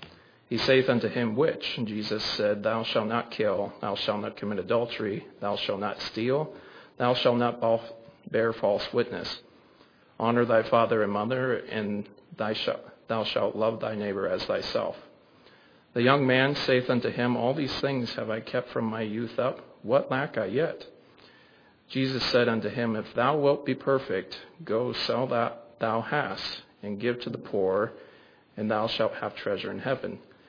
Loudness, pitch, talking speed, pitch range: -28 LUFS, 120 Hz, 170 wpm, 110-130 Hz